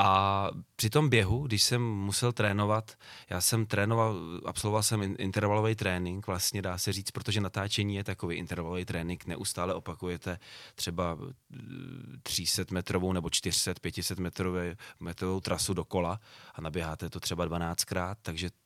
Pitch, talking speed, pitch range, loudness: 95 Hz, 135 wpm, 90-105 Hz, -31 LUFS